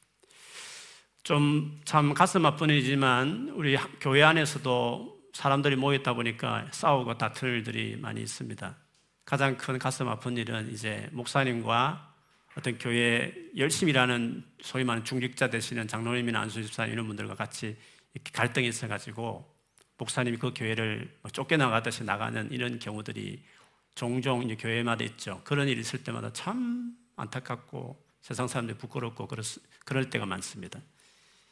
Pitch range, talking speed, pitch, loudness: 115-140 Hz, 330 characters per minute, 125 Hz, -29 LUFS